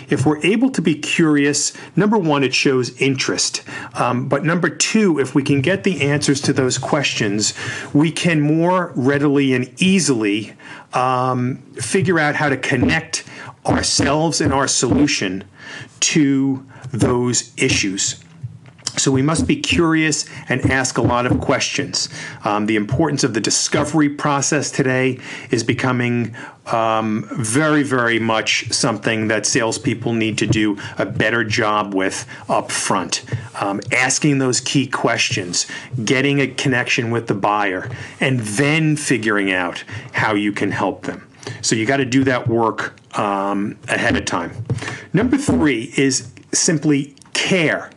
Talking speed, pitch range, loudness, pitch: 145 wpm, 115-145 Hz, -18 LUFS, 135 Hz